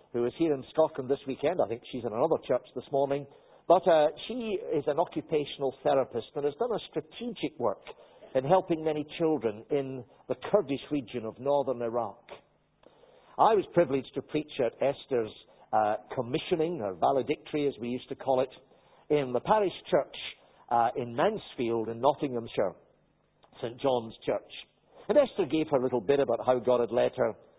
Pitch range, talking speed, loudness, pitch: 125-155 Hz, 175 wpm, -30 LUFS, 140 Hz